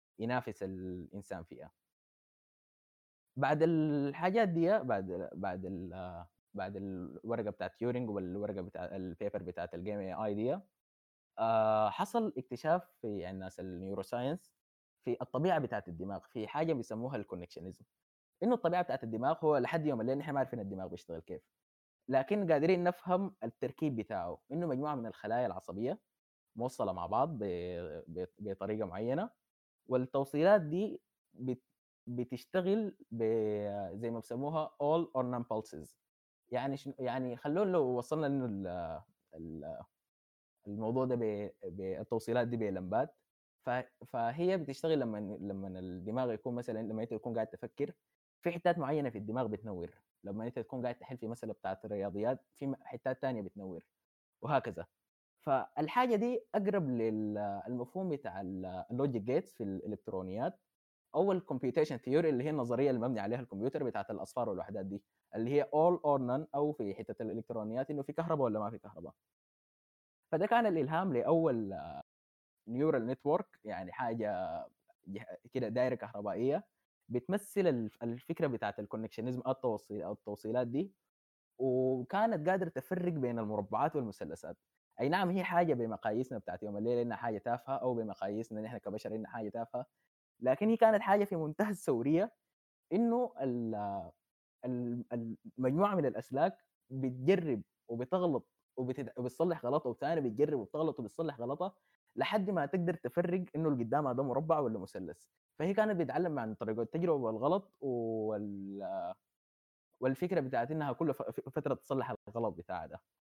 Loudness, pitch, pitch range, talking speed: -36 LUFS, 125 Hz, 110-160 Hz, 130 wpm